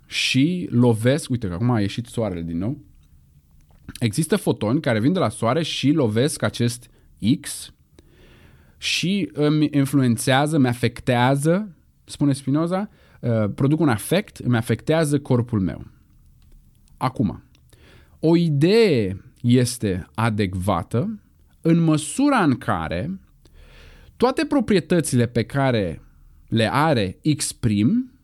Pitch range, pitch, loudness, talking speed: 100-150 Hz, 120 Hz, -21 LUFS, 110 wpm